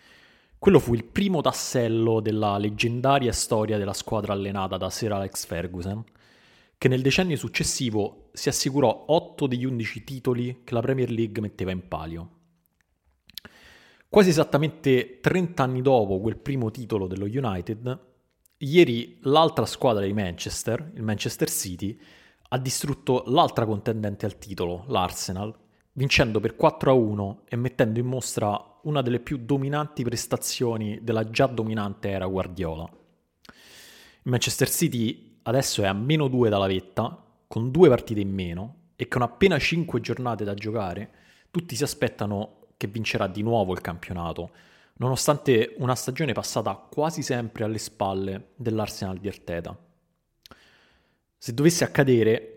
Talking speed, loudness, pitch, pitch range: 135 wpm, -25 LUFS, 115 Hz, 100-130 Hz